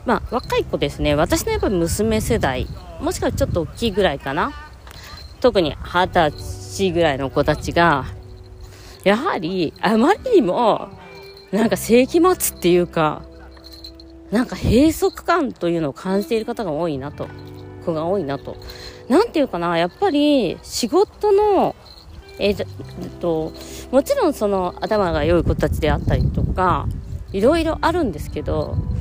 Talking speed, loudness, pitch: 290 characters per minute, -19 LUFS, 185 Hz